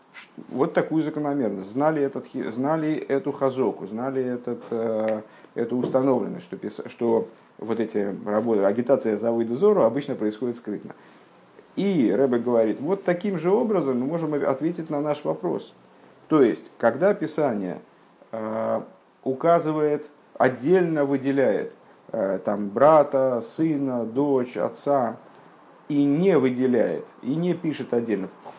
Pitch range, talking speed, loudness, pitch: 115-150 Hz, 125 wpm, -24 LUFS, 135 Hz